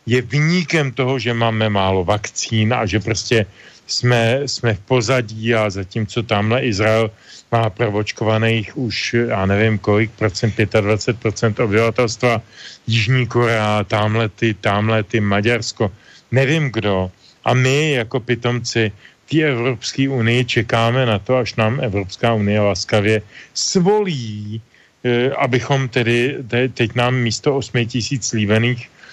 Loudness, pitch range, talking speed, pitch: -18 LUFS, 110-125 Hz, 125 wpm, 115 Hz